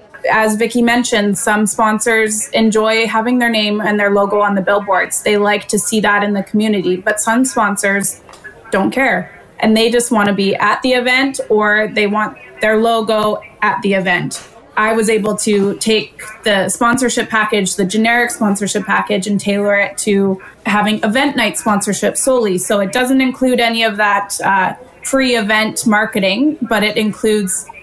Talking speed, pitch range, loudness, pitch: 170 wpm, 205-230 Hz, -14 LUFS, 215 Hz